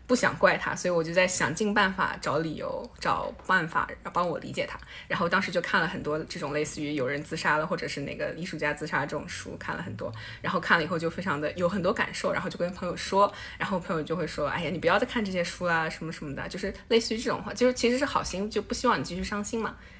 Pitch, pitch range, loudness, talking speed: 175 Hz, 155-205 Hz, -28 LUFS, 395 characters per minute